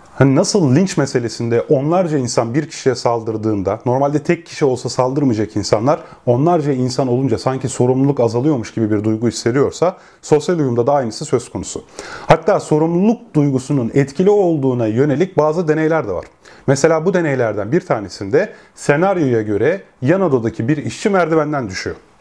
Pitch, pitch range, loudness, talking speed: 140 Hz, 120-160 Hz, -16 LUFS, 145 wpm